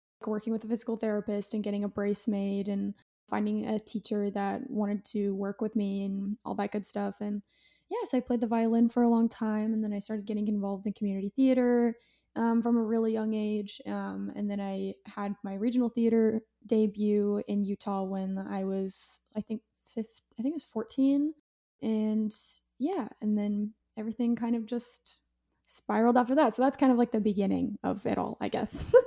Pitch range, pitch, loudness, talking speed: 205-235 Hz, 215 Hz, -30 LUFS, 200 wpm